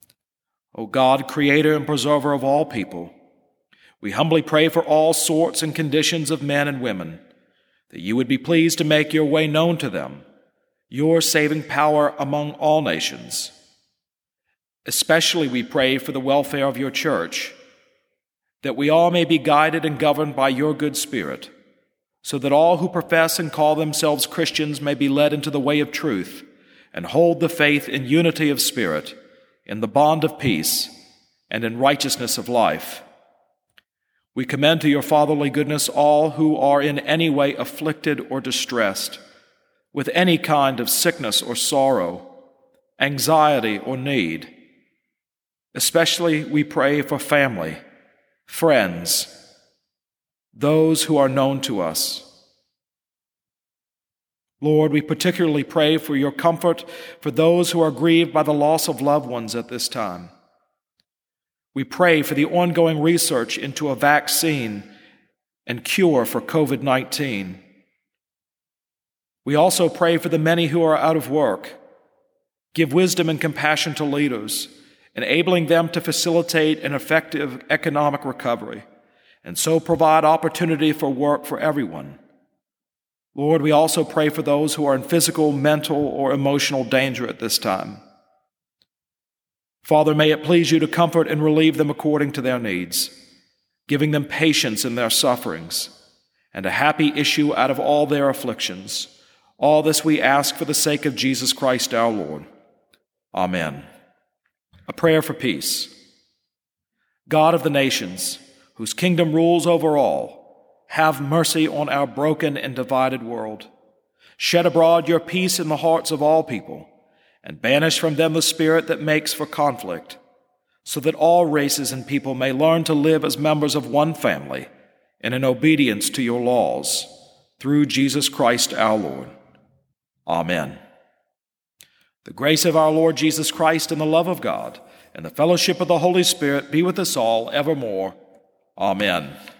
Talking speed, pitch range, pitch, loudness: 150 wpm, 140-160 Hz, 150 Hz, -19 LUFS